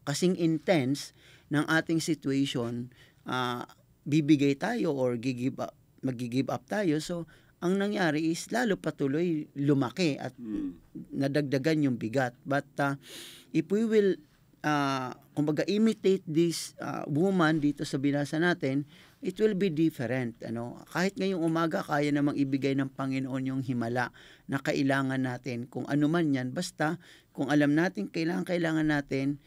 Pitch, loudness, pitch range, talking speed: 150 Hz, -29 LUFS, 135-165 Hz, 135 wpm